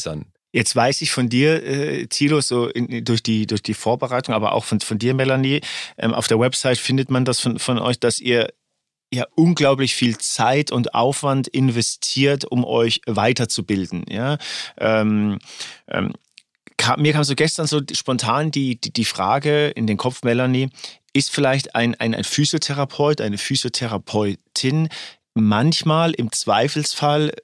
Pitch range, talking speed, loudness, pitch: 115-140 Hz, 155 wpm, -19 LUFS, 125 Hz